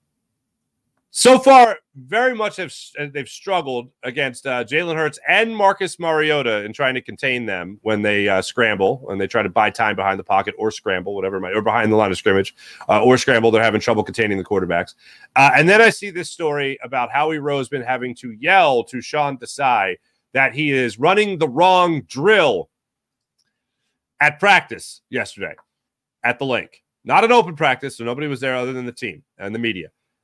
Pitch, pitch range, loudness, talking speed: 135 Hz, 115-160 Hz, -17 LUFS, 190 wpm